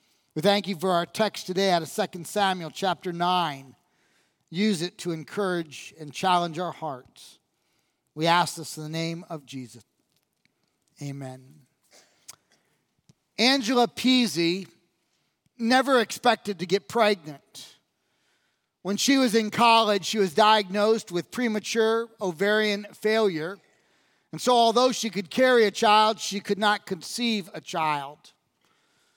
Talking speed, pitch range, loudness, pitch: 130 wpm, 170-220 Hz, -24 LUFS, 195 Hz